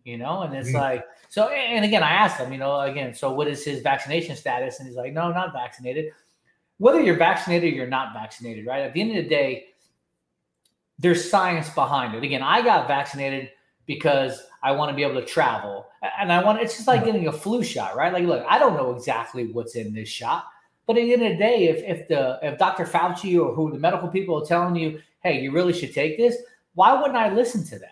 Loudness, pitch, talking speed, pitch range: -23 LUFS, 160 Hz, 240 wpm, 135-185 Hz